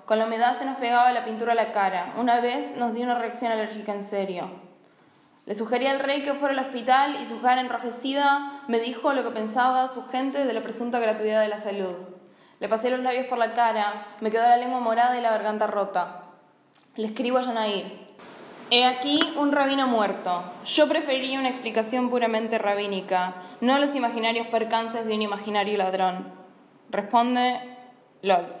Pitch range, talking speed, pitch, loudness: 205-250 Hz, 185 wpm, 230 Hz, -25 LUFS